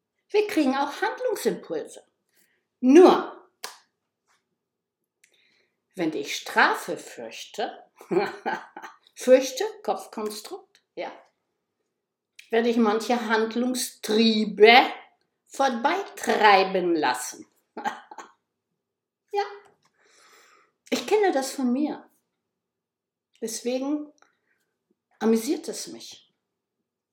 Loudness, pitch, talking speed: -23 LUFS, 275 Hz, 60 wpm